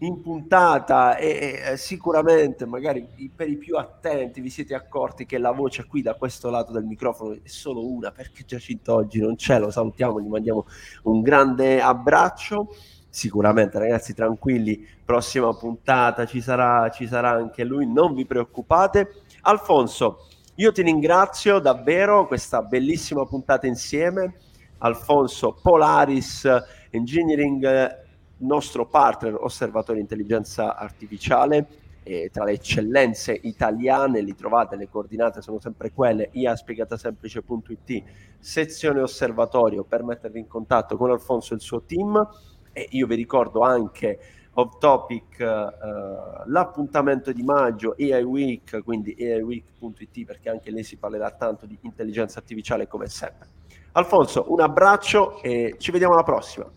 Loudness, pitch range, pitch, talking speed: -22 LUFS, 110-140 Hz, 125 Hz, 135 wpm